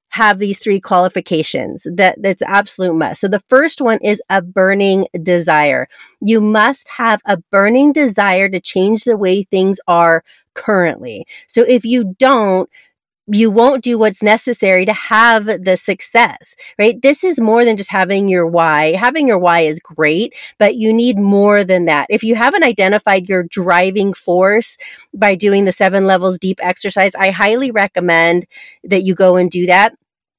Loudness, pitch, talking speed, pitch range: -12 LUFS, 200 Hz, 170 wpm, 185-225 Hz